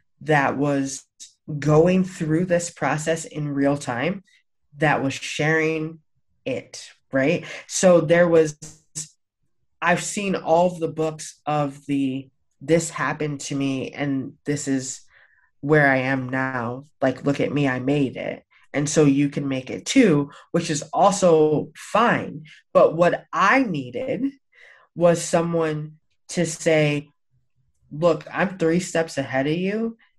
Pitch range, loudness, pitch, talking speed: 140-170 Hz, -22 LUFS, 155 Hz, 135 wpm